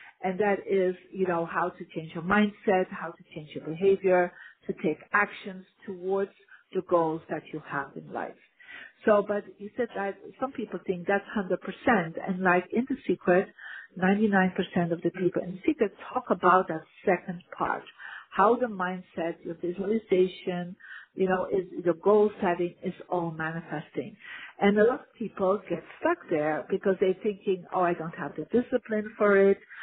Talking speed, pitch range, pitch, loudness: 175 wpm, 175-205 Hz, 190 Hz, -28 LUFS